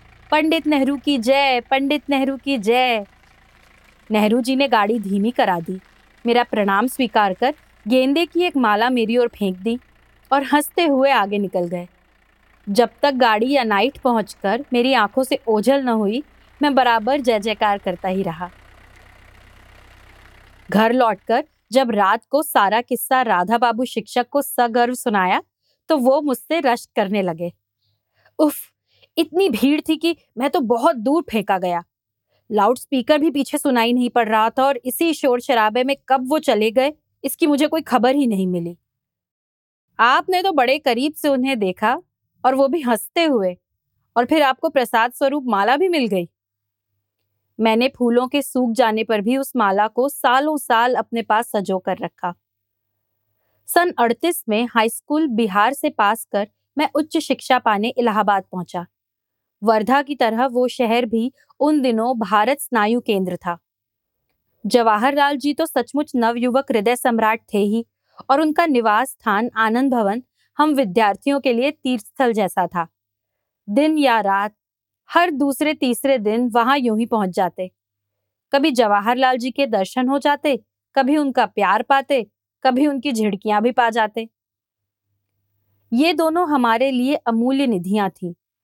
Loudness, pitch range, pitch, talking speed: -19 LUFS, 200-275 Hz, 240 Hz, 155 wpm